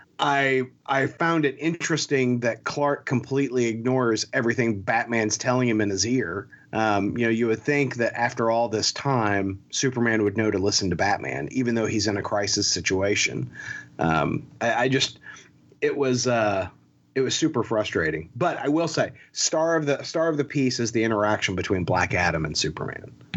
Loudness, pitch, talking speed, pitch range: -24 LUFS, 120 Hz, 180 wpm, 105-135 Hz